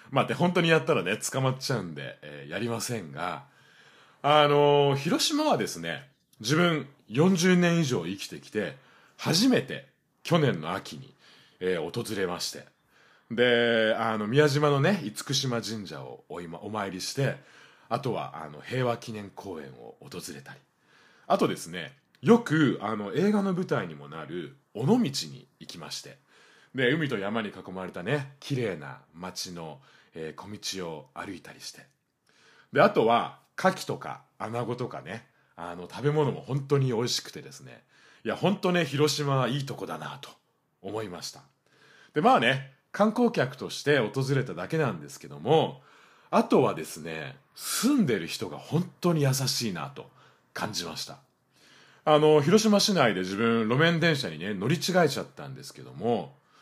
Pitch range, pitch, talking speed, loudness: 115-160 Hz, 140 Hz, 290 characters per minute, -27 LUFS